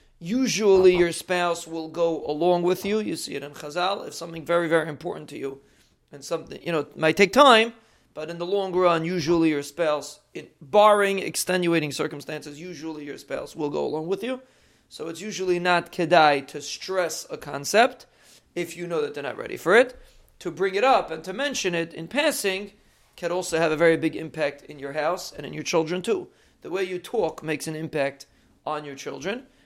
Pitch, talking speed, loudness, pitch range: 170 Hz, 205 wpm, -24 LUFS, 155-195 Hz